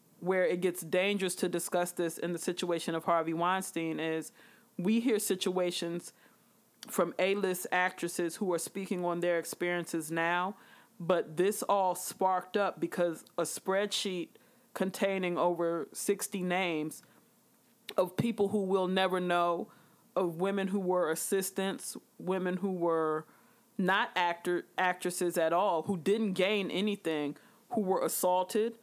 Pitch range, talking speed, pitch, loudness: 175-200 Hz, 135 wpm, 185 Hz, -32 LUFS